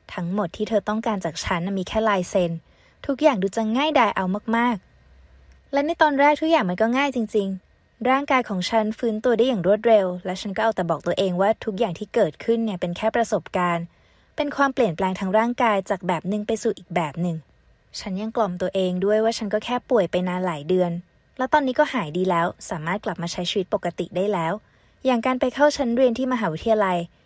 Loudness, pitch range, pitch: -23 LUFS, 180-235 Hz, 210 Hz